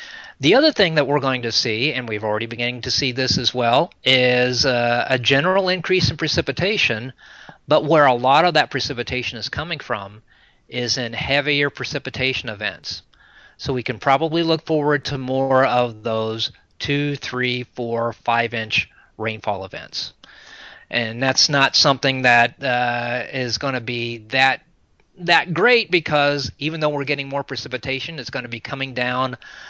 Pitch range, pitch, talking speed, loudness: 120-145 Hz, 130 Hz, 165 wpm, -19 LUFS